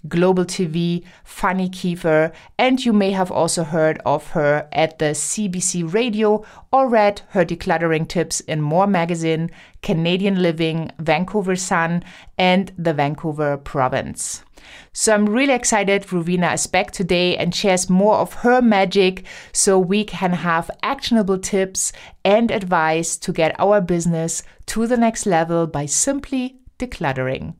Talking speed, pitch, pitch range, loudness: 140 wpm, 180 Hz, 165-205 Hz, -19 LUFS